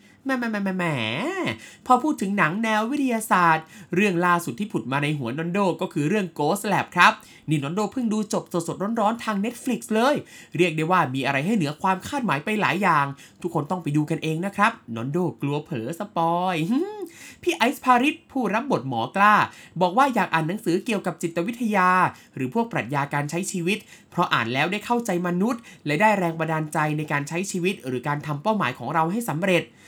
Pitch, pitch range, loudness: 180 Hz, 160-215 Hz, -23 LUFS